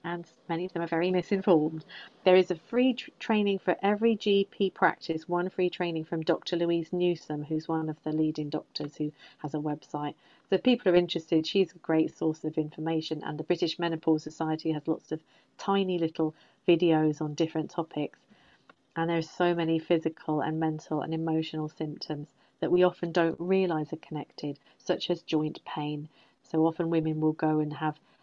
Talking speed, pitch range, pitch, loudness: 185 wpm, 155-175 Hz, 160 Hz, -29 LUFS